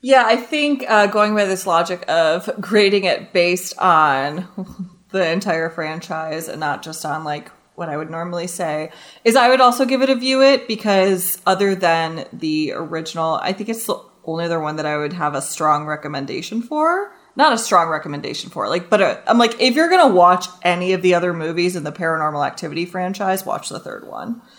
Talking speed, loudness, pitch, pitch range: 205 wpm, -18 LUFS, 180 Hz, 160-225 Hz